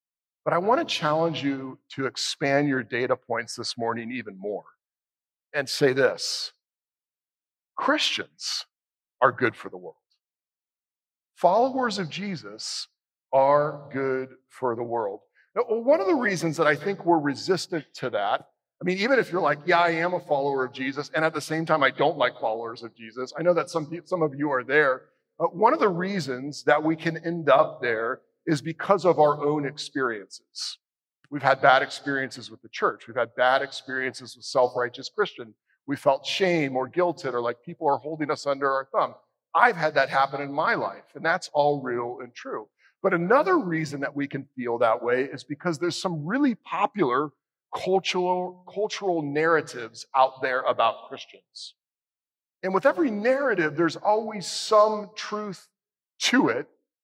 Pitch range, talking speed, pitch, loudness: 135-185 Hz, 175 wpm, 155 Hz, -25 LUFS